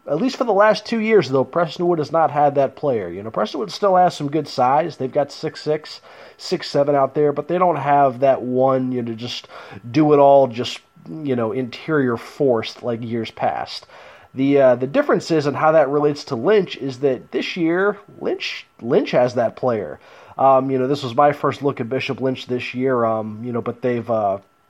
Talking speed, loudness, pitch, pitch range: 220 wpm, -19 LUFS, 140 Hz, 125-160 Hz